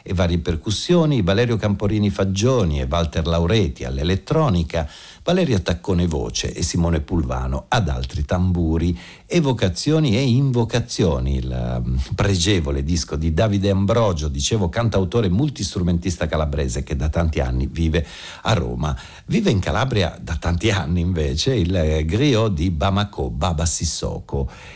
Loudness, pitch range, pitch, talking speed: -20 LUFS, 80-105 Hz, 90 Hz, 125 wpm